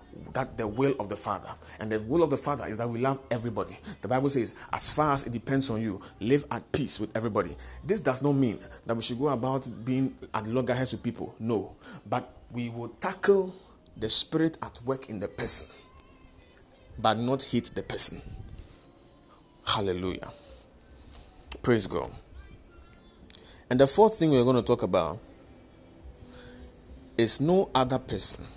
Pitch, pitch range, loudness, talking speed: 120 Hz, 95-135 Hz, -25 LUFS, 165 wpm